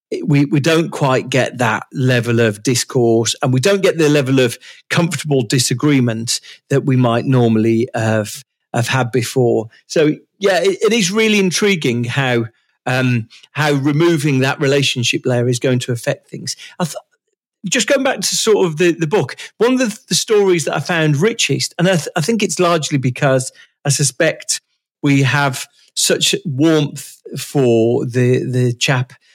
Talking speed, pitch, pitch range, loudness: 170 wpm, 145 Hz, 125-175 Hz, -15 LUFS